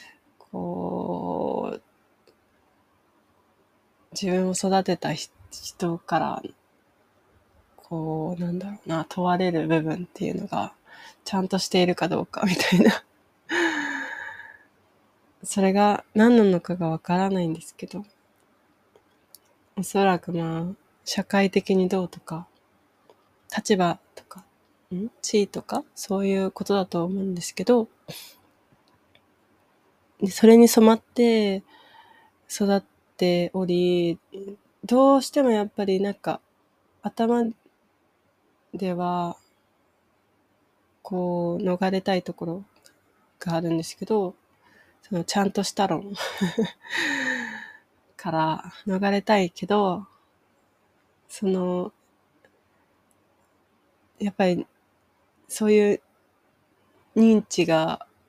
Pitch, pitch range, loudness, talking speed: 190 Hz, 175-205 Hz, -24 LUFS, 180 characters per minute